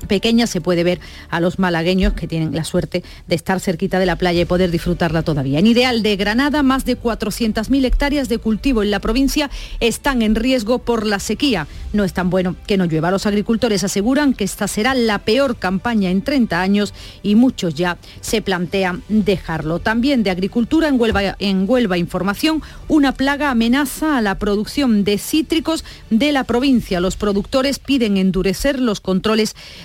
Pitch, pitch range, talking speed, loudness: 210 Hz, 185-250 Hz, 180 wpm, -17 LUFS